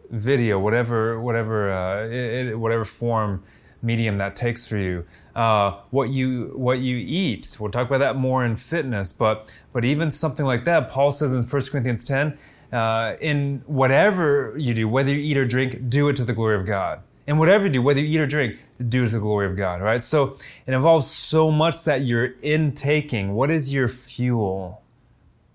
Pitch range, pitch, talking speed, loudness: 110-140 Hz, 125 Hz, 195 wpm, -21 LUFS